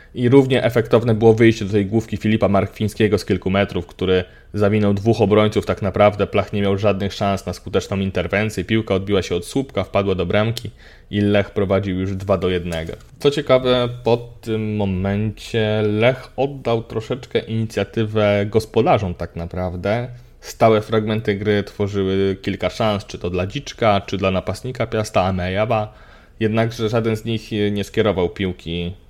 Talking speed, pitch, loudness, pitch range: 155 wpm, 105 Hz, -19 LUFS, 95-110 Hz